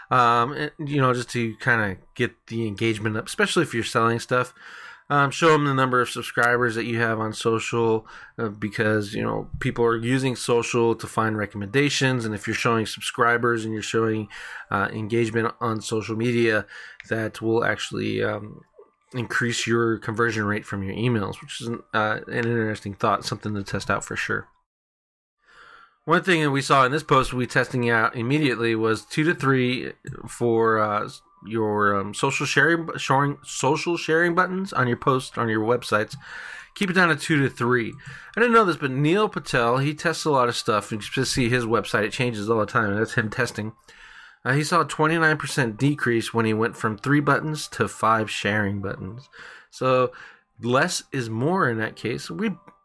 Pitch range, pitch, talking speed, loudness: 110-140 Hz, 120 Hz, 190 wpm, -23 LUFS